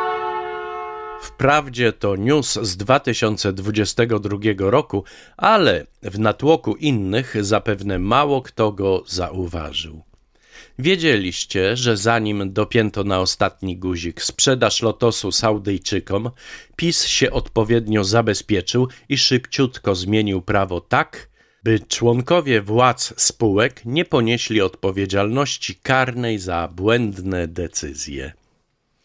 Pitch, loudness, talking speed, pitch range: 105 Hz, -19 LUFS, 95 wpm, 95-120 Hz